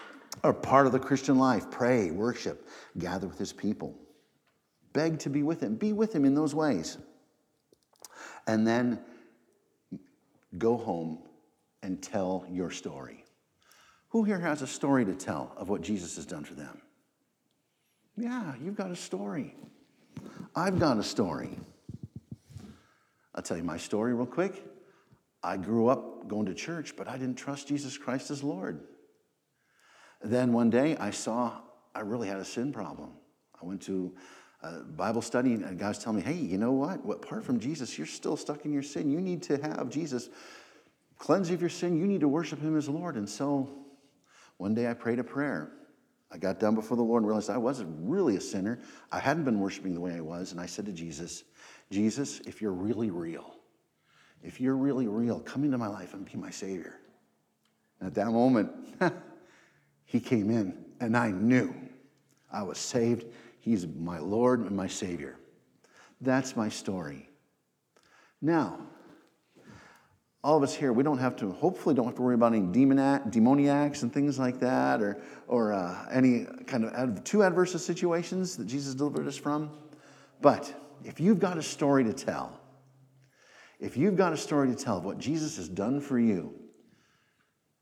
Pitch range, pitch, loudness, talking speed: 110-150 Hz, 130 Hz, -30 LUFS, 175 wpm